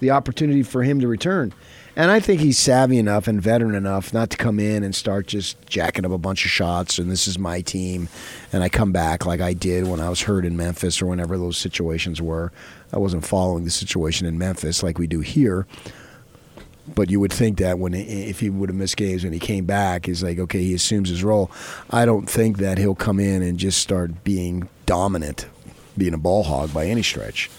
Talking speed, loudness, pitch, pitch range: 225 wpm, -21 LUFS, 95 Hz, 90-105 Hz